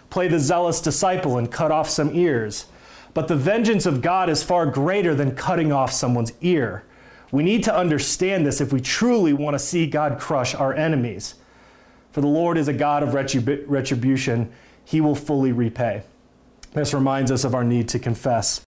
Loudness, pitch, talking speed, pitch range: -21 LUFS, 145 Hz, 185 wpm, 130-160 Hz